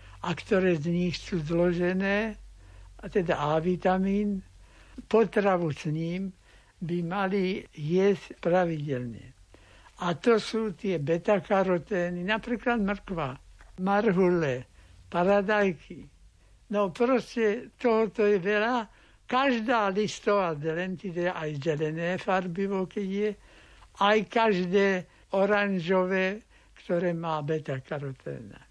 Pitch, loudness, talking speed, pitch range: 185 Hz, -28 LUFS, 95 wpm, 165-205 Hz